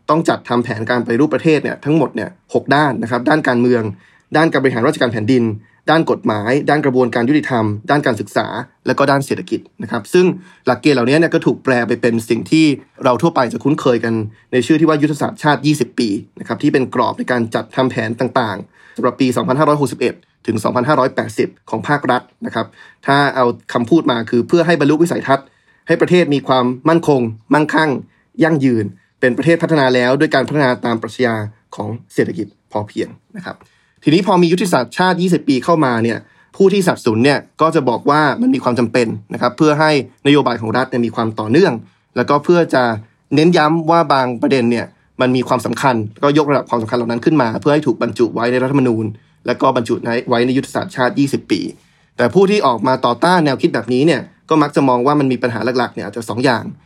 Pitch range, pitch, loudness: 120-155 Hz, 130 Hz, -15 LUFS